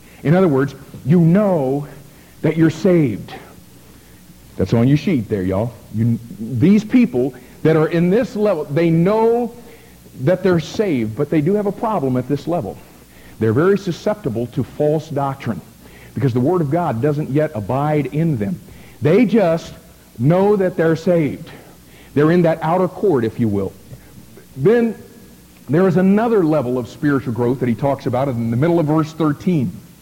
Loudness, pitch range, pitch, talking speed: -17 LUFS, 120-175 Hz, 150 Hz, 170 wpm